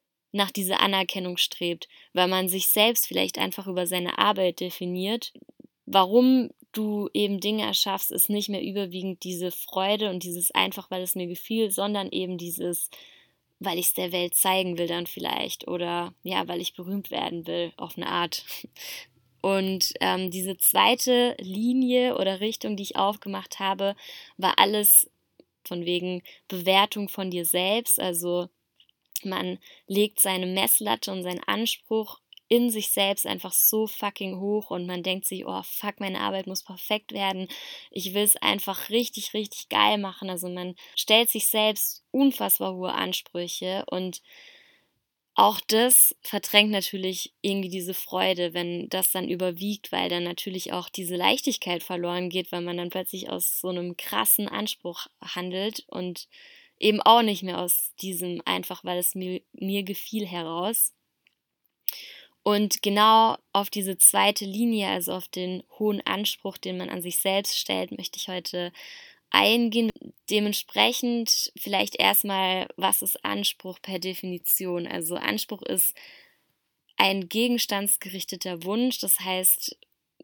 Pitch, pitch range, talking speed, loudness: 190 Hz, 180-210 Hz, 145 wpm, -25 LUFS